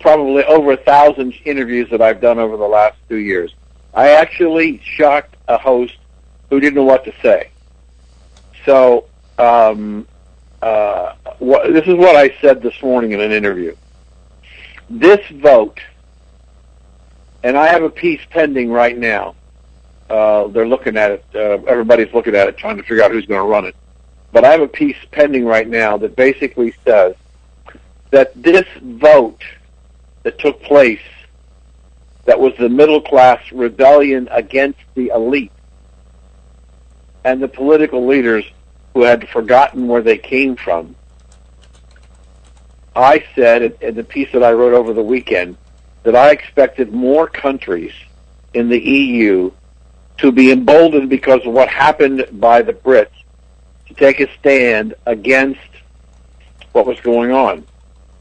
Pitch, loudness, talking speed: 110 Hz, -12 LUFS, 145 wpm